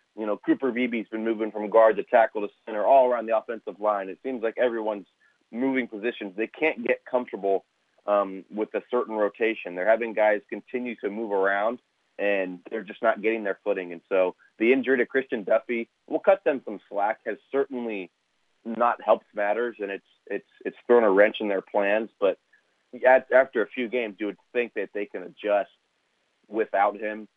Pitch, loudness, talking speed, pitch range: 110 Hz, -26 LUFS, 195 wpm, 105-125 Hz